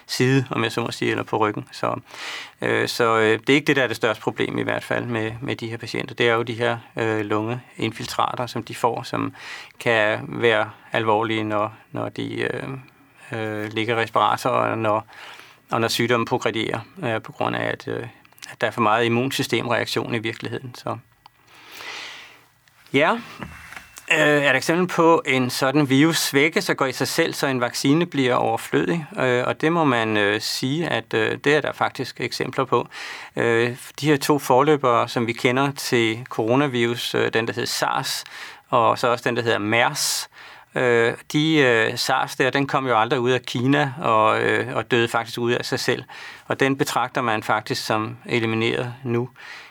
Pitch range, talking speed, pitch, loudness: 115-140 Hz, 175 wpm, 125 Hz, -21 LUFS